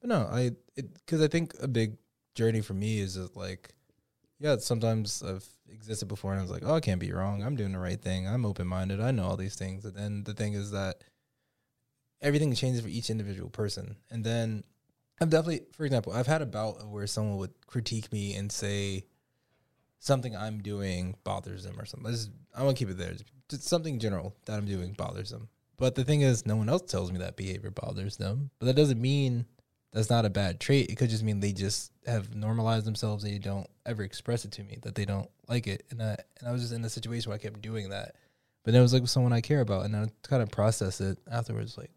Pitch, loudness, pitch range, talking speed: 110 Hz, -31 LUFS, 100-125 Hz, 240 wpm